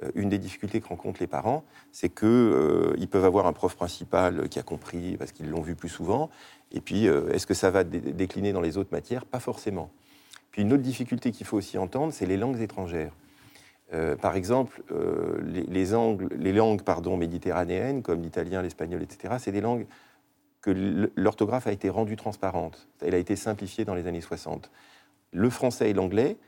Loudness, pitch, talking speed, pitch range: -28 LUFS, 100 Hz, 195 wpm, 90-110 Hz